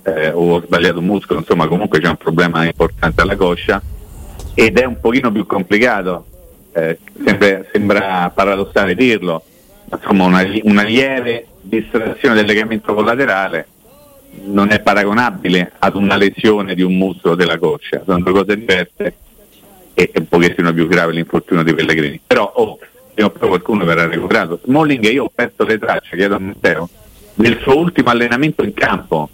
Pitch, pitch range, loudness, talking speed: 95 Hz, 85-105 Hz, -14 LUFS, 160 wpm